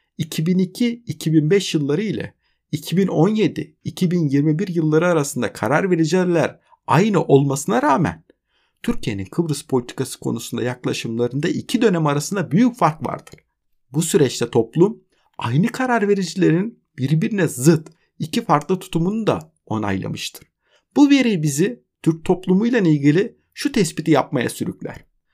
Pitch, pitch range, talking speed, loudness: 165 Hz, 145-195 Hz, 105 wpm, -19 LUFS